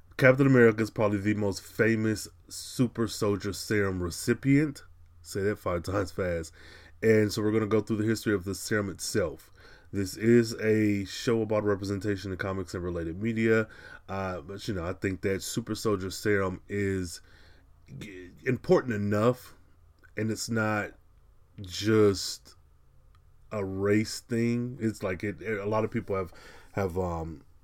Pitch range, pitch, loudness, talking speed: 90-110 Hz, 100 Hz, -29 LUFS, 150 wpm